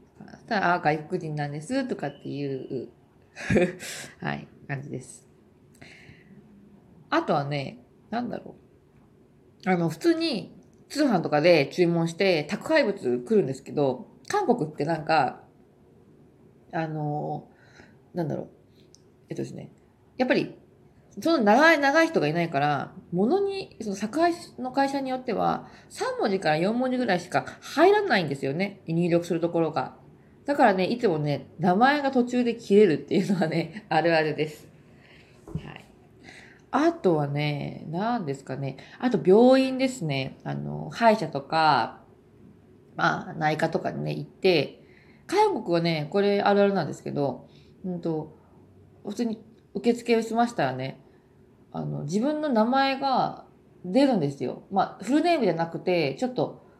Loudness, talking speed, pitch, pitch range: -25 LUFS, 270 characters per minute, 185 Hz, 155-245 Hz